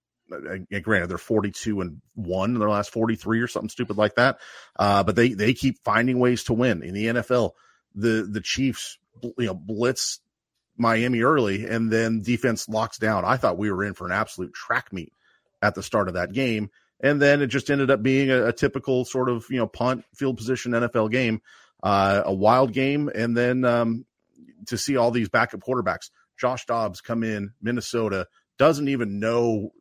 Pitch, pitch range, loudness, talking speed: 115 Hz, 105-130 Hz, -23 LUFS, 195 wpm